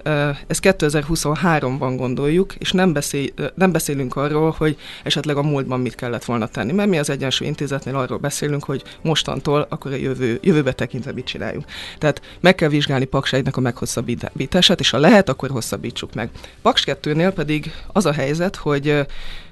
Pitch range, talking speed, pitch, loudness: 130-155 Hz, 165 wpm, 145 Hz, -19 LUFS